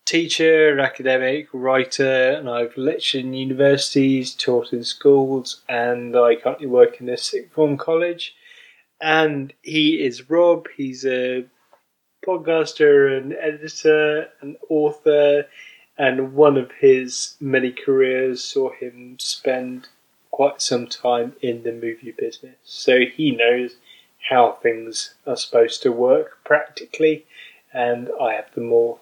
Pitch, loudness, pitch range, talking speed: 140 Hz, -19 LUFS, 125-160 Hz, 130 wpm